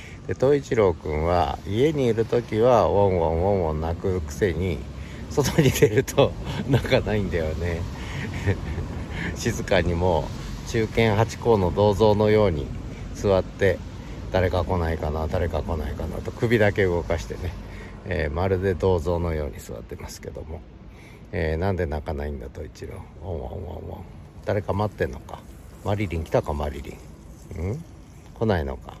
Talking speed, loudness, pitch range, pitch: 315 characters per minute, -24 LUFS, 80-105 Hz, 90 Hz